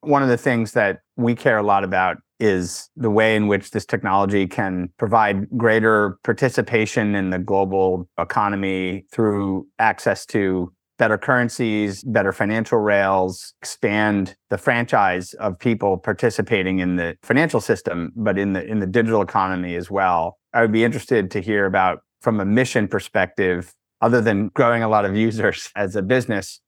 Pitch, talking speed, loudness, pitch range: 100 Hz, 165 wpm, -20 LUFS, 95-115 Hz